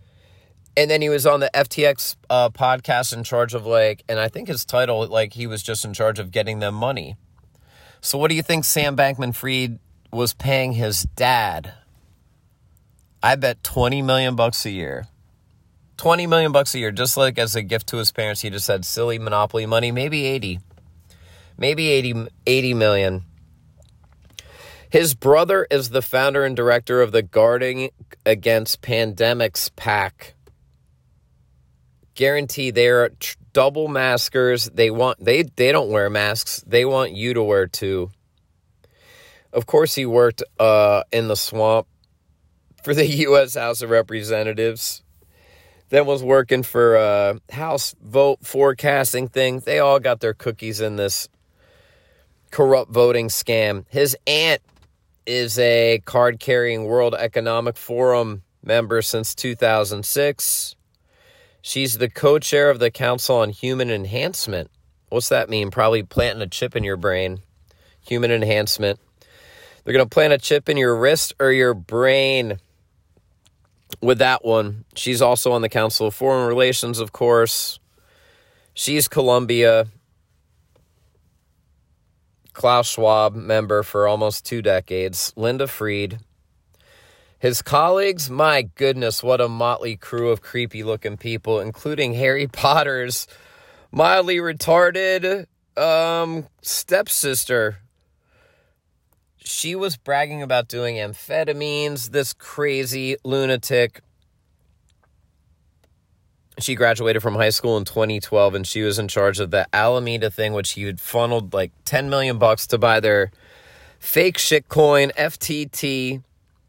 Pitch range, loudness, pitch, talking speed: 105-135 Hz, -19 LUFS, 120 Hz, 135 wpm